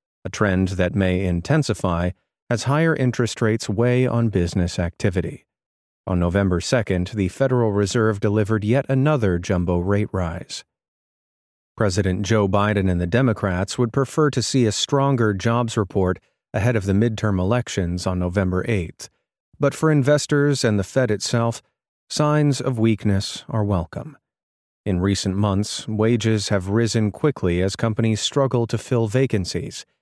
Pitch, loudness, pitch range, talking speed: 105 Hz, -21 LUFS, 95-120 Hz, 145 wpm